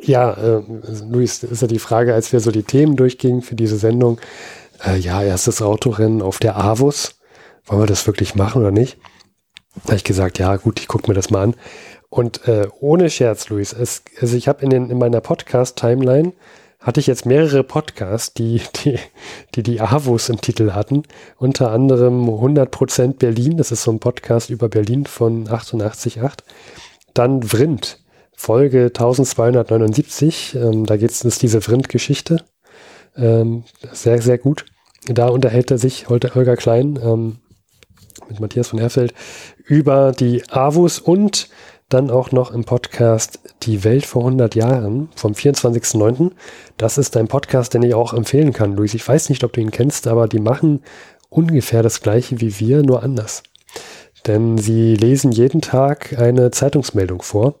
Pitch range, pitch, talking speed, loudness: 115-135 Hz, 120 Hz, 165 wpm, -16 LUFS